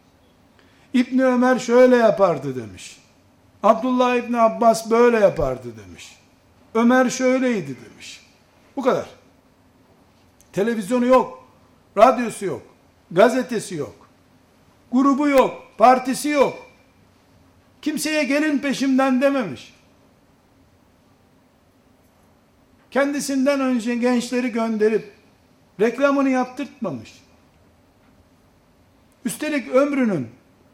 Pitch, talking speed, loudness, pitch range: 245 Hz, 75 wpm, -19 LUFS, 210-265 Hz